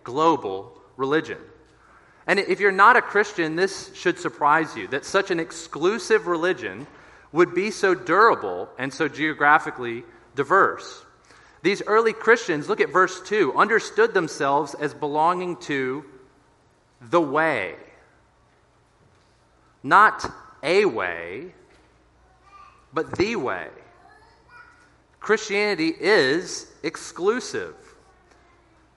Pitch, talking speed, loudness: 195 Hz, 100 wpm, -22 LUFS